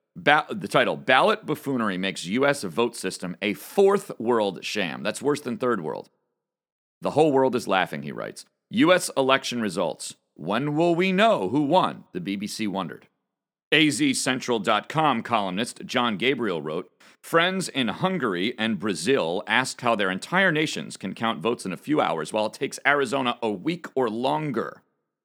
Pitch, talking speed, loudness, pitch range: 130 Hz, 160 wpm, -24 LUFS, 105-150 Hz